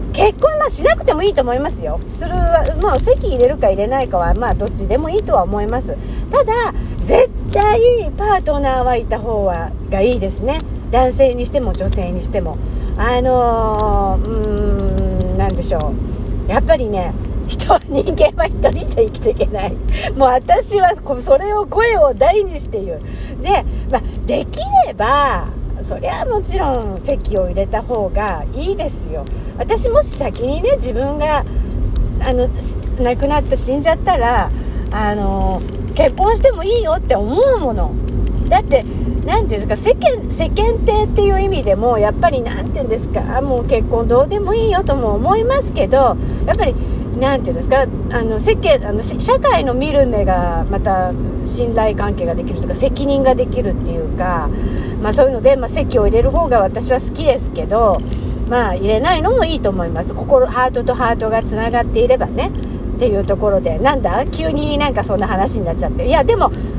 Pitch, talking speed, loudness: 275 Hz, 335 characters per minute, -16 LUFS